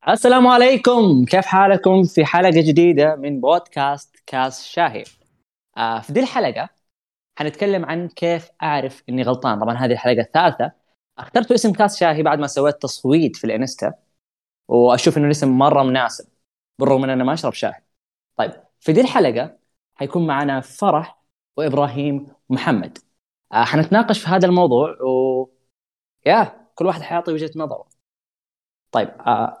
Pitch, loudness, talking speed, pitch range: 150 Hz, -17 LUFS, 140 wpm, 130-175 Hz